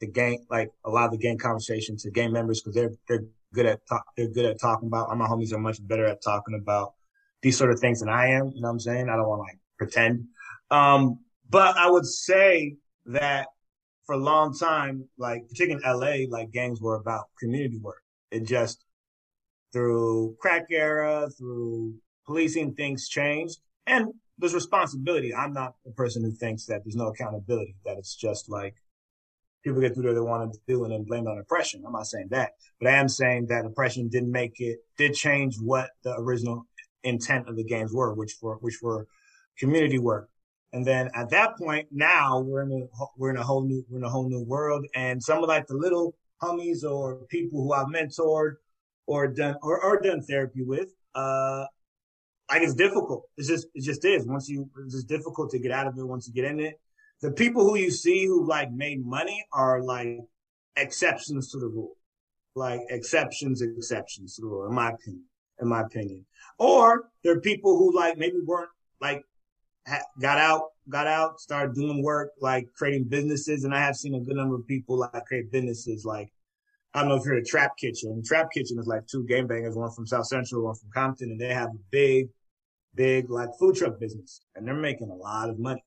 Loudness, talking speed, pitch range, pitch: -26 LUFS, 210 wpm, 115-150 Hz, 130 Hz